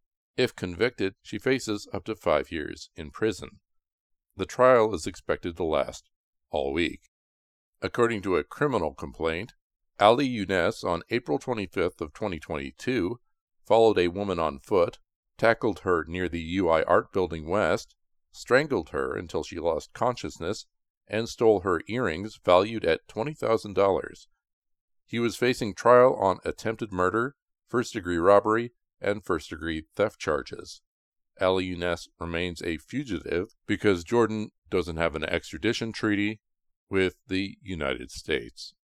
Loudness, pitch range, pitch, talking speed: -27 LUFS, 85-110 Hz, 100 Hz, 140 wpm